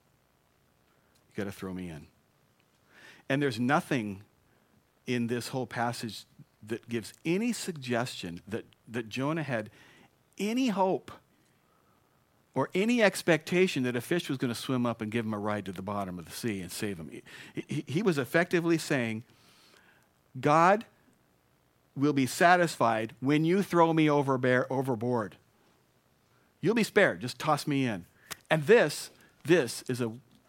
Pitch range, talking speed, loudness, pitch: 110-155 Hz, 150 wpm, -29 LUFS, 125 Hz